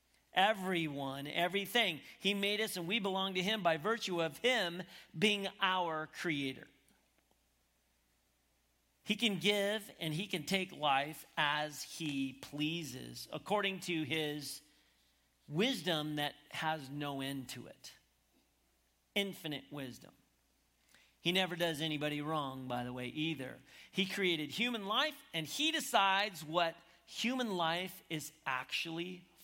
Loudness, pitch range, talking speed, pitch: -36 LUFS, 140-190 Hz, 125 wpm, 160 Hz